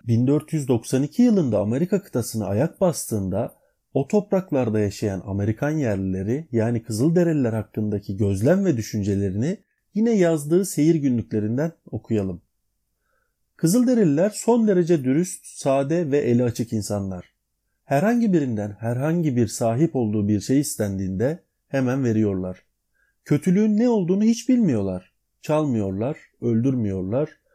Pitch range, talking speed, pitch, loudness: 110-170 Hz, 105 wpm, 130 Hz, -22 LUFS